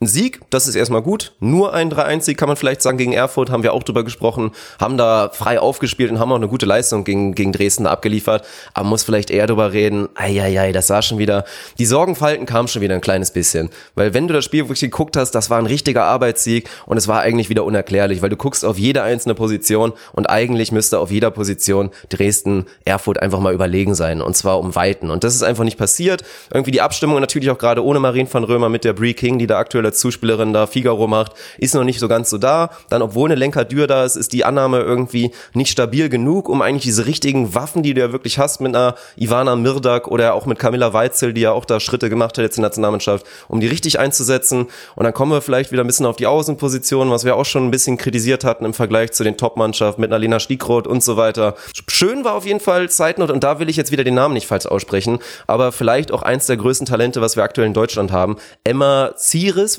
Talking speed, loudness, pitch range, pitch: 245 wpm, -16 LUFS, 110-135 Hz, 120 Hz